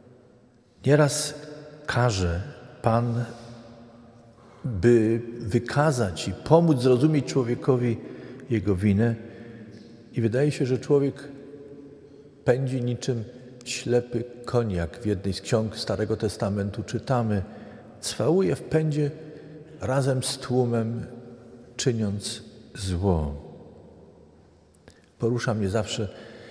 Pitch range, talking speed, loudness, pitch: 110-130 Hz, 85 wpm, -25 LUFS, 120 Hz